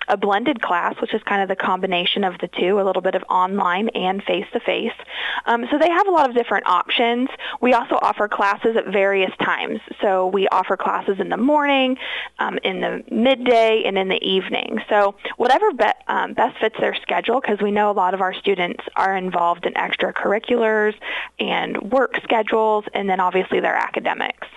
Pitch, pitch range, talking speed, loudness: 210 Hz, 190-245 Hz, 190 wpm, -19 LUFS